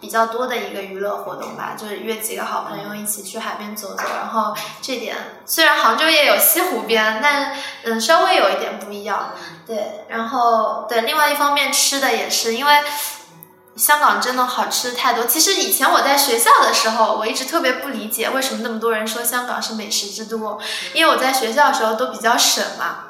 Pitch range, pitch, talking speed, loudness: 220-280 Hz, 230 Hz, 310 characters per minute, -17 LUFS